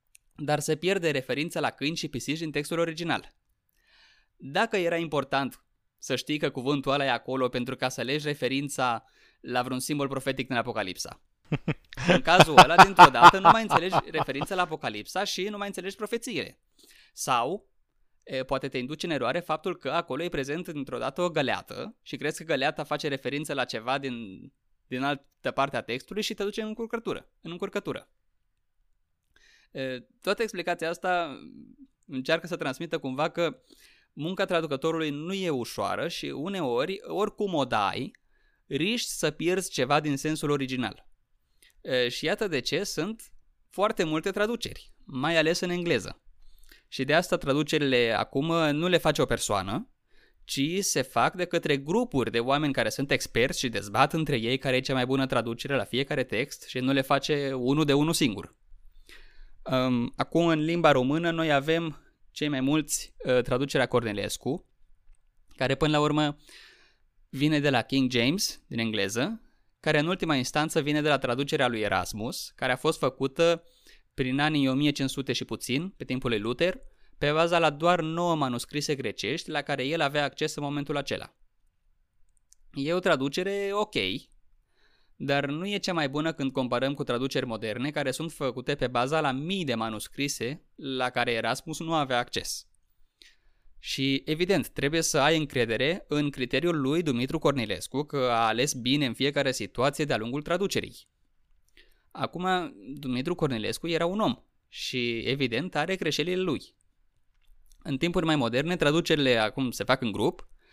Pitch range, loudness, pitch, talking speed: 130-165 Hz, -27 LUFS, 145 Hz, 160 wpm